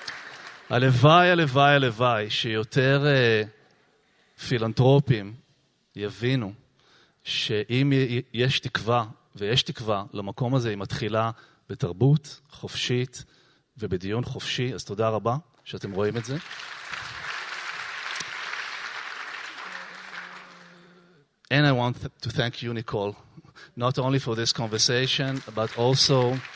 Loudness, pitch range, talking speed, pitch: -25 LUFS, 115-140 Hz, 95 wpm, 125 Hz